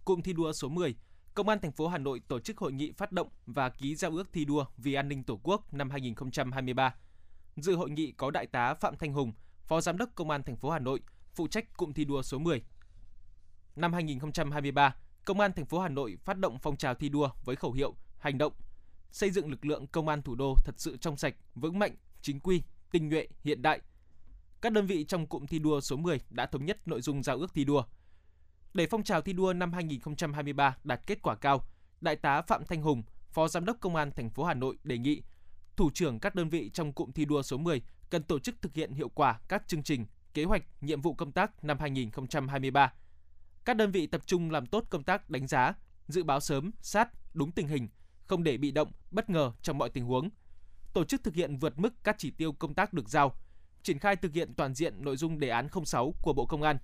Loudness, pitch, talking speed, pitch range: -33 LUFS, 150 Hz, 235 wpm, 130-175 Hz